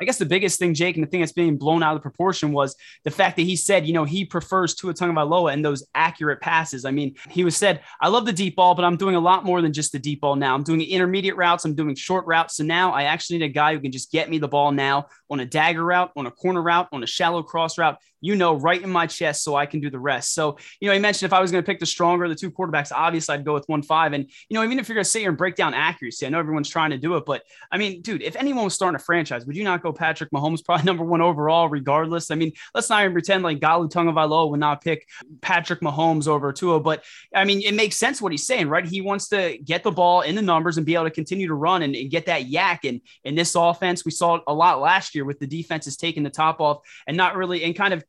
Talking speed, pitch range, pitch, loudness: 300 wpm, 150-180 Hz, 165 Hz, -21 LUFS